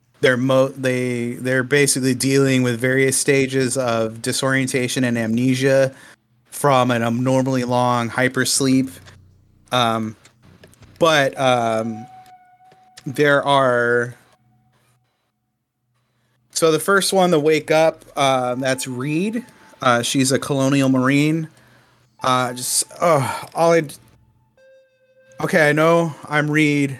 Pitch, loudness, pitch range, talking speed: 130 Hz, -18 LUFS, 125-145 Hz, 105 wpm